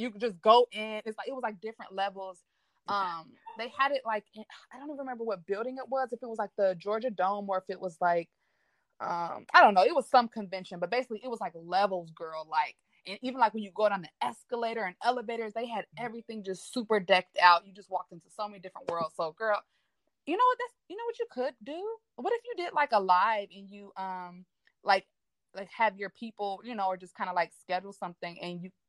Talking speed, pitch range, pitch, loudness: 245 wpm, 185-245 Hz, 210 Hz, -31 LUFS